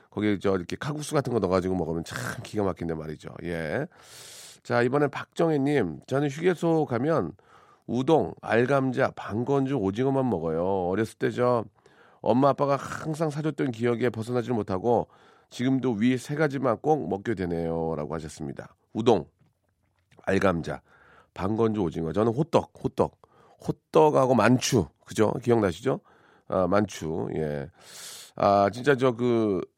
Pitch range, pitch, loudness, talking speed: 95-140 Hz, 120 Hz, -26 LUFS, 290 characters per minute